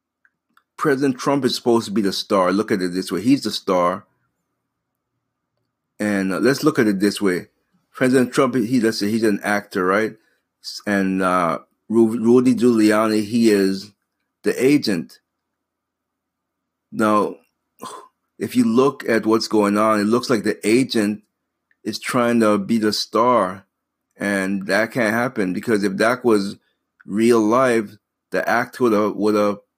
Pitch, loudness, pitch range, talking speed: 110 Hz, -19 LUFS, 100-120 Hz, 150 wpm